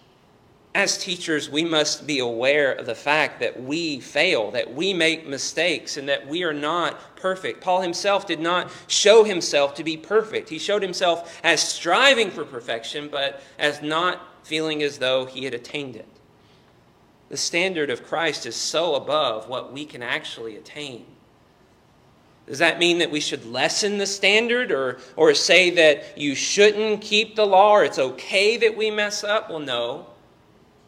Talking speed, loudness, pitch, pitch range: 170 wpm, -21 LUFS, 170 Hz, 145-205 Hz